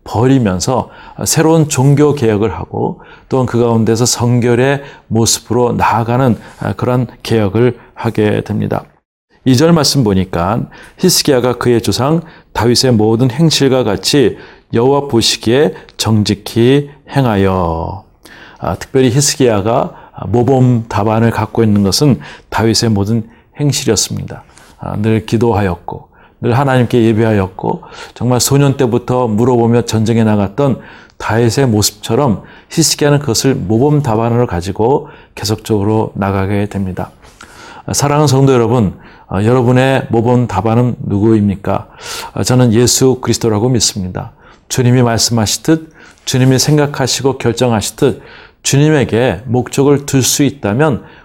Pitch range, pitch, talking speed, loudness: 110-130 Hz, 120 Hz, 290 characters per minute, -12 LUFS